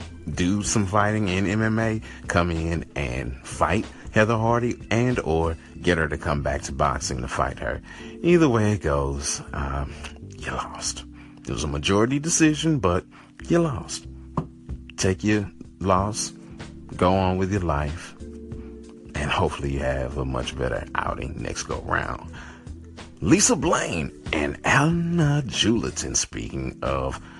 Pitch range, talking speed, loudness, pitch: 70-105 Hz, 145 wpm, -24 LUFS, 85 Hz